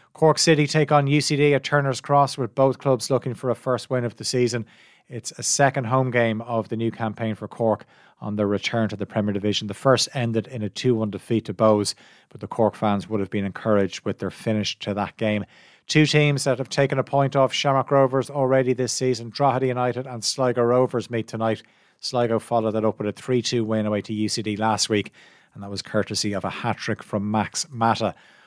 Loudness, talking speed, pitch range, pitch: -23 LUFS, 215 wpm, 105-130 Hz, 115 Hz